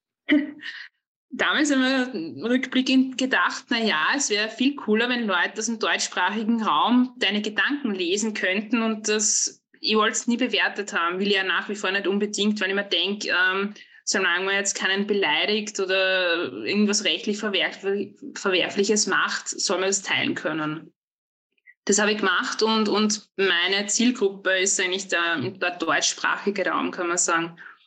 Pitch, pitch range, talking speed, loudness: 210 Hz, 190-230 Hz, 160 wpm, -23 LUFS